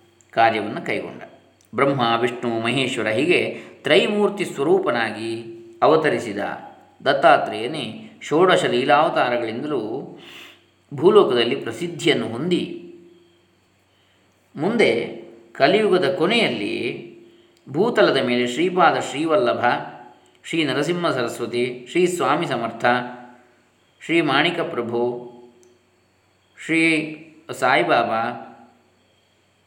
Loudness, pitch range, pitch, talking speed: -20 LUFS, 110-155 Hz, 120 Hz, 65 wpm